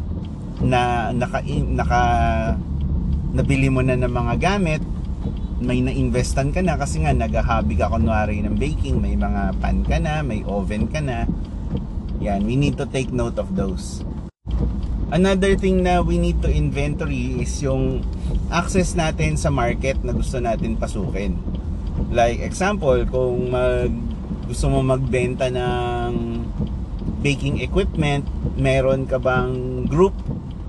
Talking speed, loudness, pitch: 135 wpm, -21 LUFS, 100 Hz